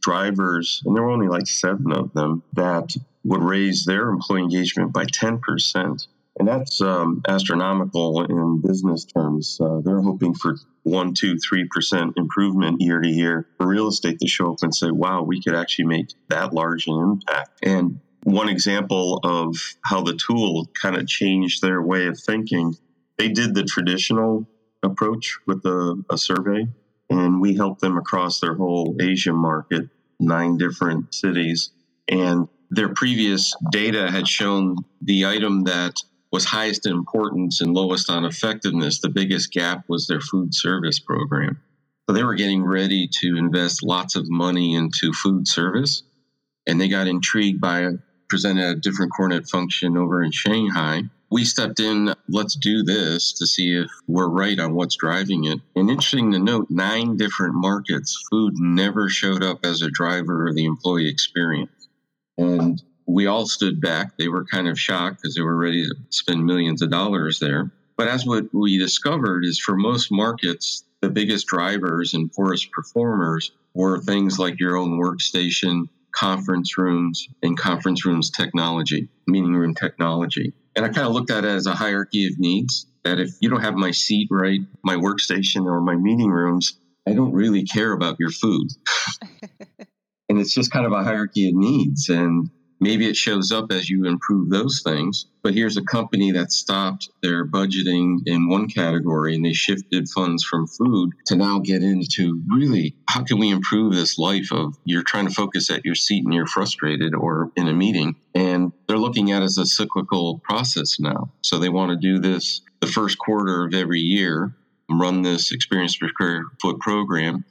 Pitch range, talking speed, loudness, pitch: 85-100 Hz, 175 wpm, -21 LUFS, 90 Hz